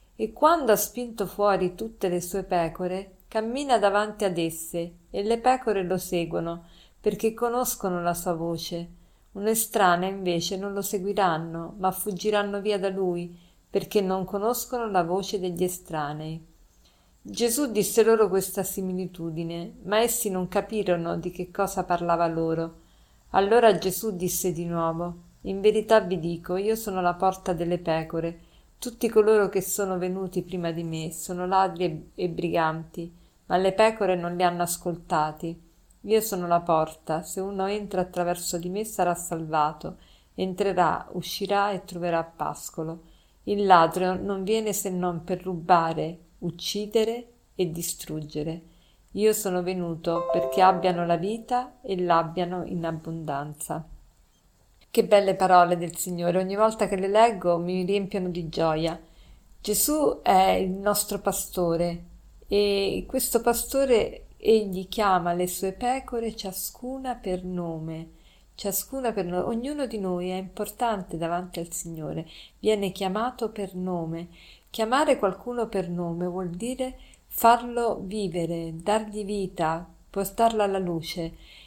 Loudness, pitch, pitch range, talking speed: -26 LUFS, 185 Hz, 170-210 Hz, 135 wpm